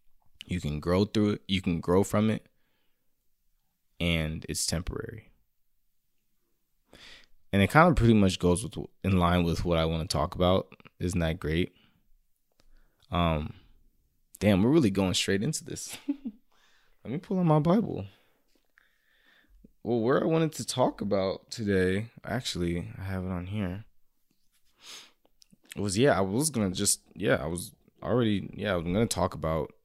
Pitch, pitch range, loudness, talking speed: 95 Hz, 85-115 Hz, -28 LUFS, 155 wpm